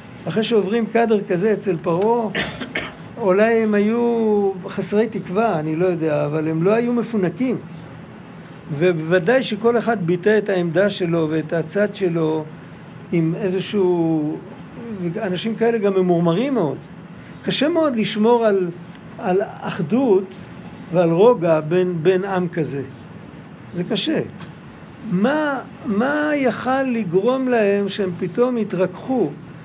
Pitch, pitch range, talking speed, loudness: 195 Hz, 175-225 Hz, 115 wpm, -19 LUFS